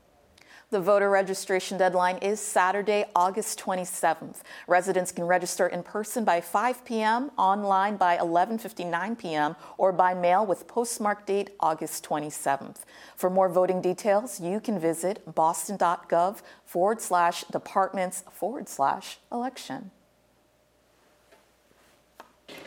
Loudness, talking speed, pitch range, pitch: -26 LUFS, 110 wpm, 175-205 Hz, 185 Hz